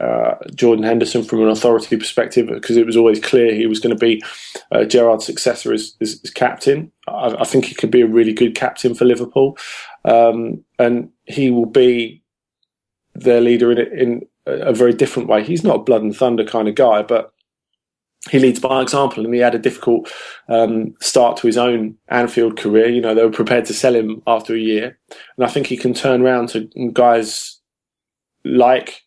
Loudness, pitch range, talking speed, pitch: -15 LUFS, 115-125 Hz, 200 wpm, 120 Hz